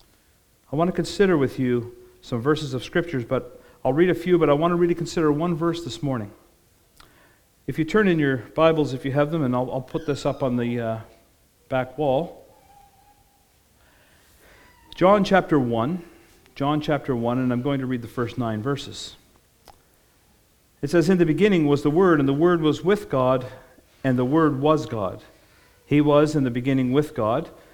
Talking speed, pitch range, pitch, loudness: 190 wpm, 125-165 Hz, 140 Hz, -22 LUFS